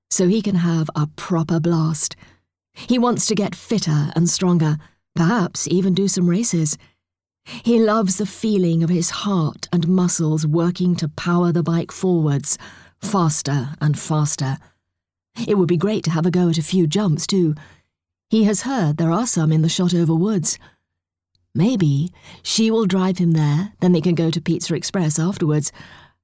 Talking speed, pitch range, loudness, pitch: 170 wpm, 155-185 Hz, -19 LUFS, 170 Hz